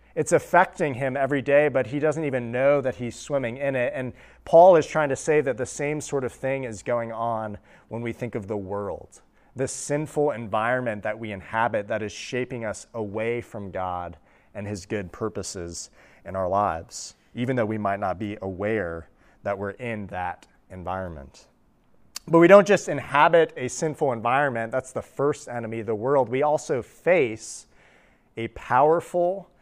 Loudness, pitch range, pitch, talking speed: -24 LUFS, 105-140 Hz, 120 Hz, 180 wpm